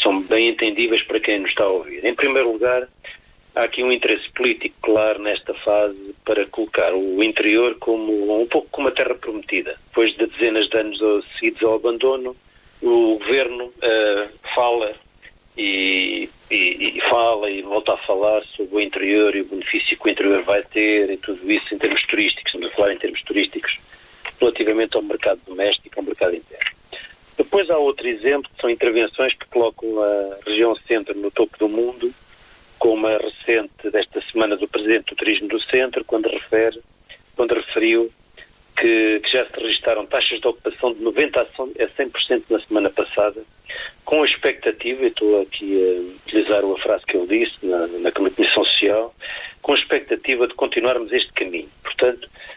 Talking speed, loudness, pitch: 170 wpm, -19 LUFS, 115 Hz